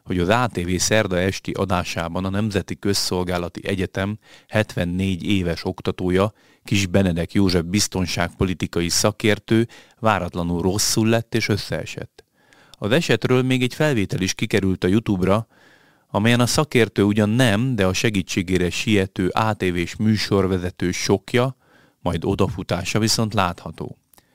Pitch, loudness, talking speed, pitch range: 100 Hz, -21 LUFS, 120 wpm, 90-110 Hz